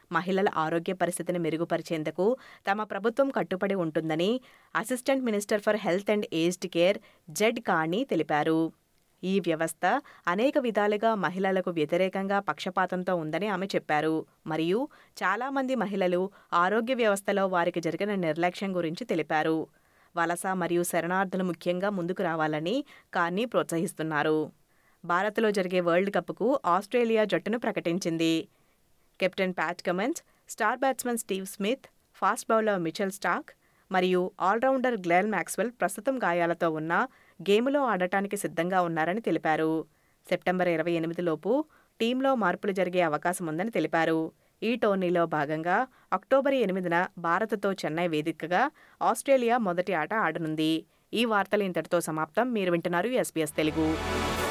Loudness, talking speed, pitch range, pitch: -28 LUFS, 110 wpm, 165-210 Hz, 180 Hz